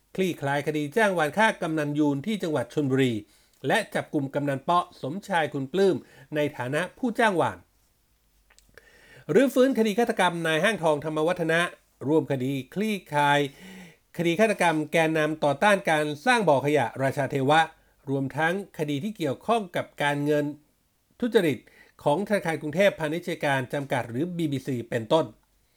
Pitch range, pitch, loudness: 145-185 Hz, 155 Hz, -25 LUFS